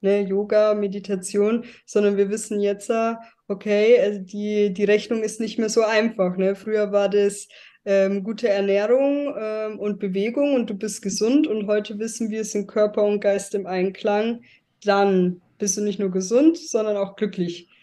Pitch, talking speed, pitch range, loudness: 210 Hz, 170 wpm, 200-220 Hz, -22 LUFS